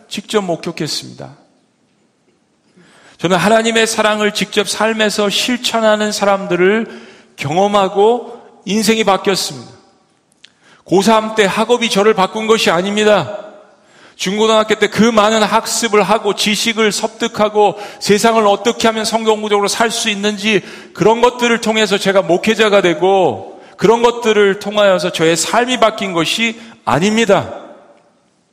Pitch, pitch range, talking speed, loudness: 210 Hz, 195-220 Hz, 285 characters per minute, -13 LUFS